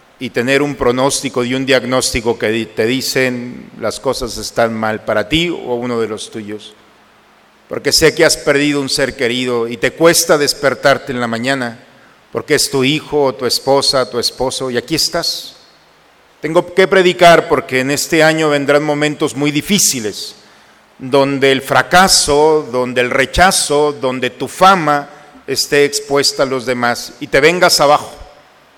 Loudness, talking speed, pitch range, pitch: -13 LUFS, 160 wpm, 125-150 Hz, 135 Hz